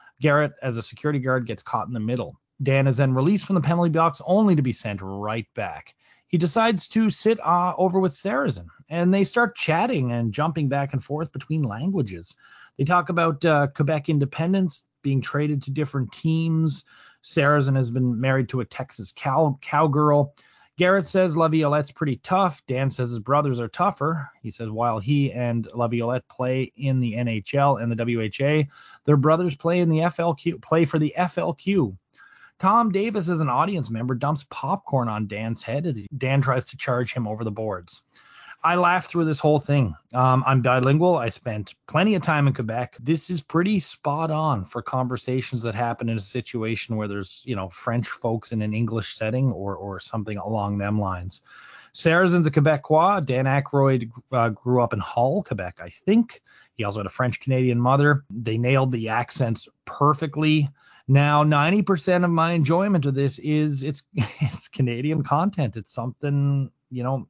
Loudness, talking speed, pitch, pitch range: -23 LUFS, 180 wpm, 140 Hz, 120-160 Hz